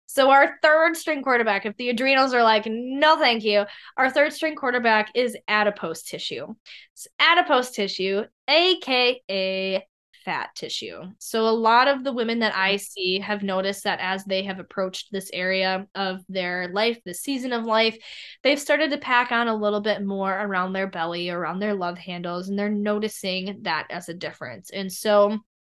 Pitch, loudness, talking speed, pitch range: 210 Hz, -22 LUFS, 175 wpm, 190-250 Hz